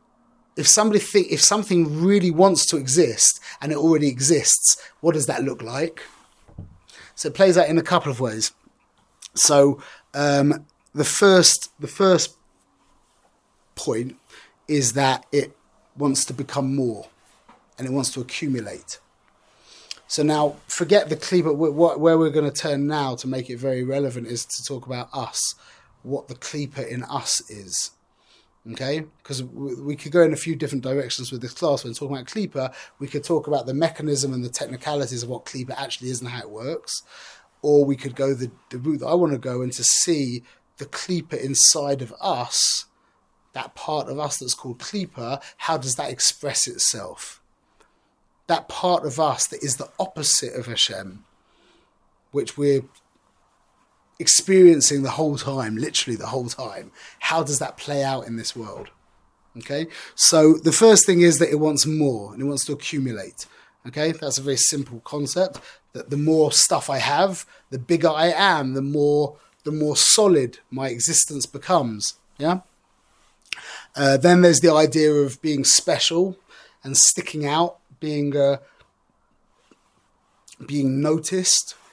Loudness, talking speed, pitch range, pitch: -20 LUFS, 165 wpm, 130-160 Hz, 145 Hz